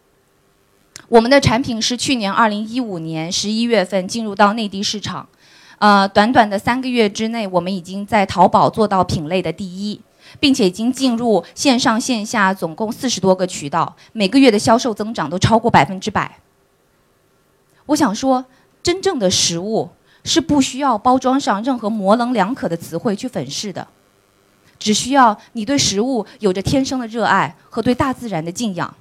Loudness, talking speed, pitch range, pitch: -17 LUFS, 270 characters per minute, 190-250 Hz, 215 Hz